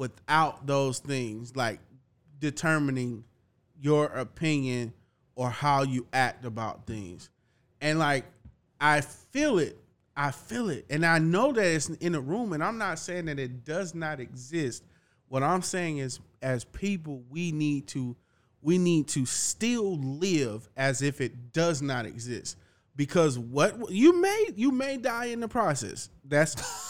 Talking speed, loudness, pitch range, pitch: 155 wpm, -28 LUFS, 125-165 Hz, 140 Hz